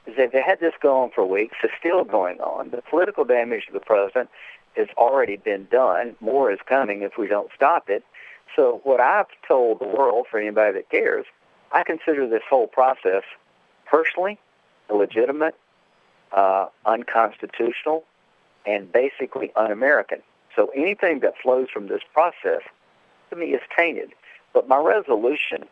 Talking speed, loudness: 150 wpm, -21 LUFS